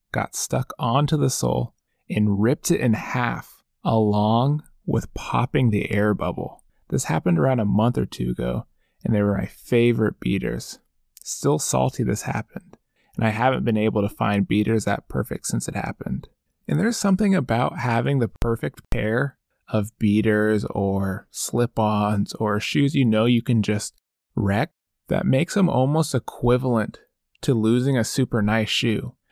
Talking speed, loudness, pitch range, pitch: 160 wpm, -23 LUFS, 105-130 Hz, 110 Hz